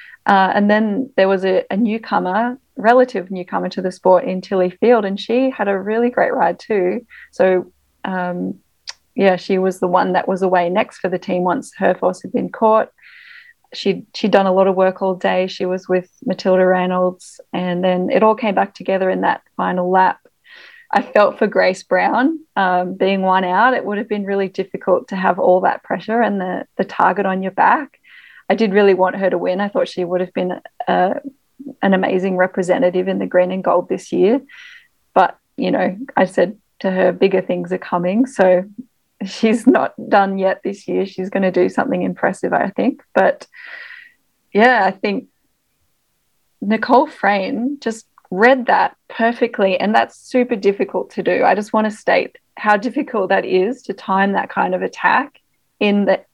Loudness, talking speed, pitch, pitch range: -17 LUFS, 190 wpm, 195 Hz, 185-240 Hz